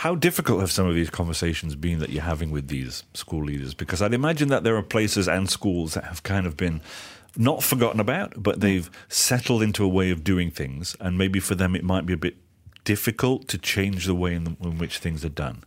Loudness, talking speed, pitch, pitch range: -24 LUFS, 235 wpm, 95 Hz, 85-105 Hz